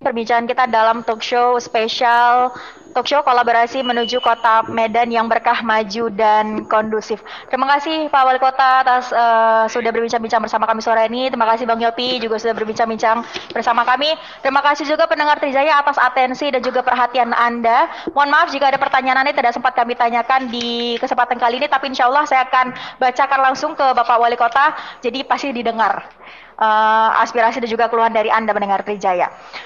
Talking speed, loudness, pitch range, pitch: 175 wpm, -16 LUFS, 230-265 Hz, 245 Hz